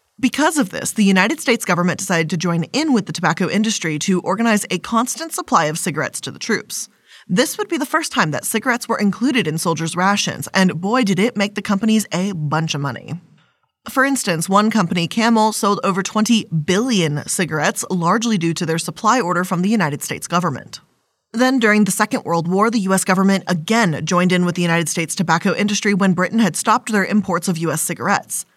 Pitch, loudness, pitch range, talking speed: 195 Hz, -18 LUFS, 170-225 Hz, 205 wpm